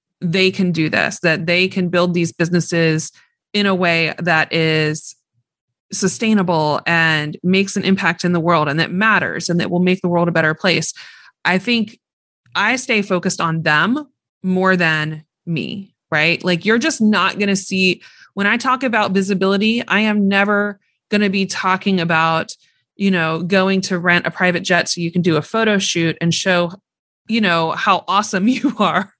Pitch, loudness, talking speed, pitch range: 185 Hz, -16 LUFS, 185 wpm, 165-200 Hz